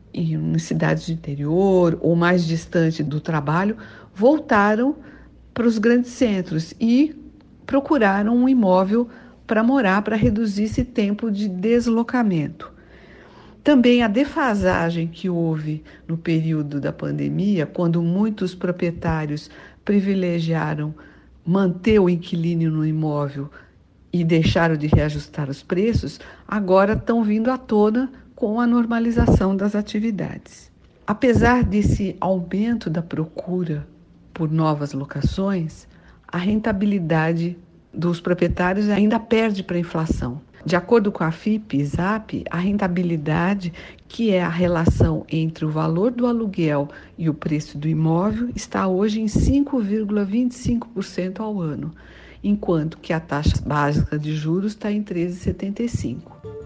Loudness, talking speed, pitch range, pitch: -21 LUFS, 120 wpm, 160-215 Hz, 180 Hz